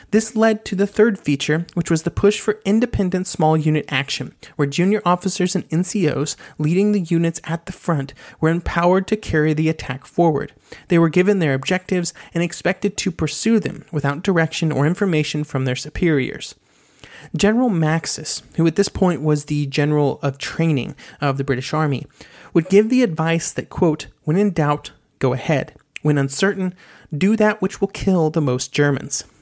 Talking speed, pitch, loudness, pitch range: 175 wpm, 165 Hz, -19 LUFS, 150-190 Hz